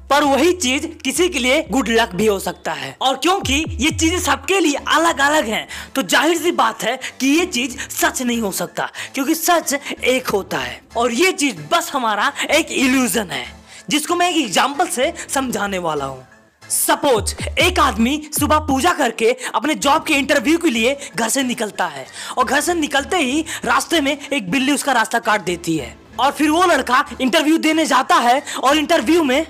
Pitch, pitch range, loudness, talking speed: 280 Hz, 245-320 Hz, -17 LUFS, 195 wpm